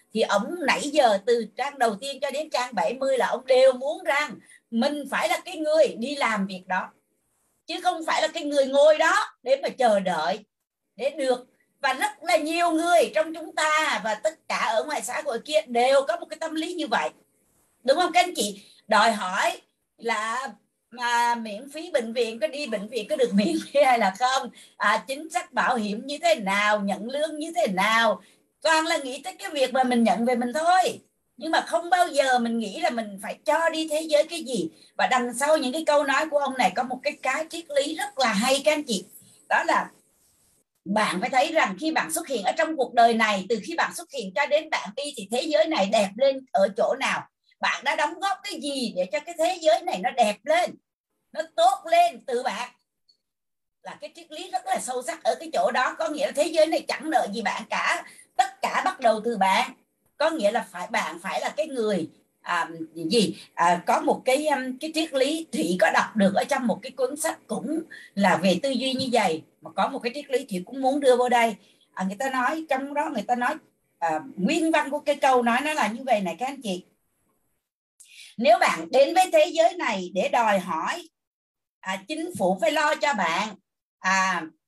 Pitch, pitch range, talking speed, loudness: 275 Hz, 230-315 Hz, 230 wpm, -24 LUFS